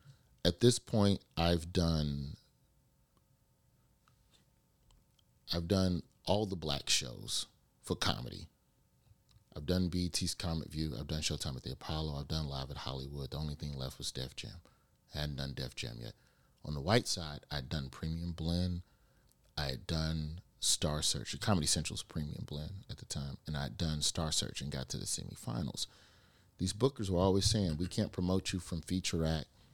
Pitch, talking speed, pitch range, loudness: 80 Hz, 170 wpm, 75-95 Hz, -36 LUFS